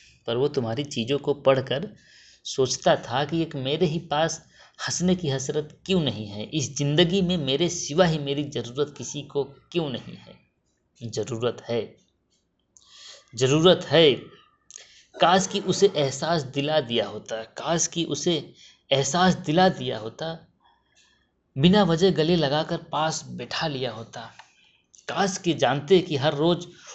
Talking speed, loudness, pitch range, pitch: 145 wpm, -24 LUFS, 135-175 Hz, 150 Hz